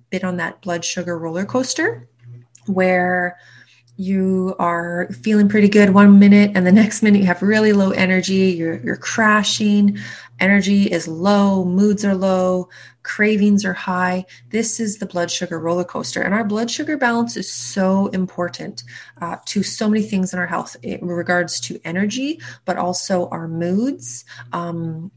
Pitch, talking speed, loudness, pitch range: 185 Hz, 160 wpm, -17 LUFS, 175-205 Hz